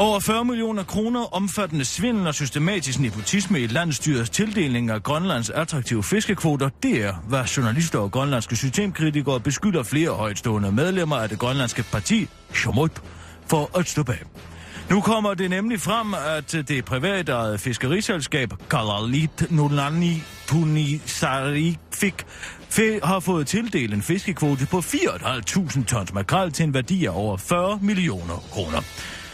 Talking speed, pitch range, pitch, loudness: 135 wpm, 120-185 Hz, 150 Hz, -23 LUFS